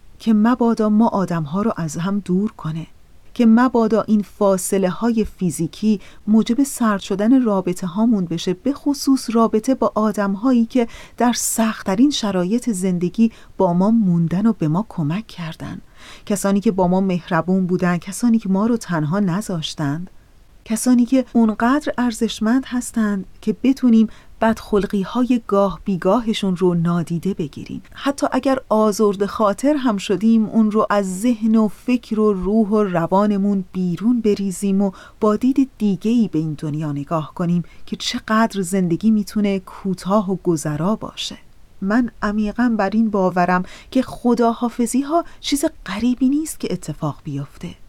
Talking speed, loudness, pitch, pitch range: 150 wpm, -19 LUFS, 210 Hz, 185-230 Hz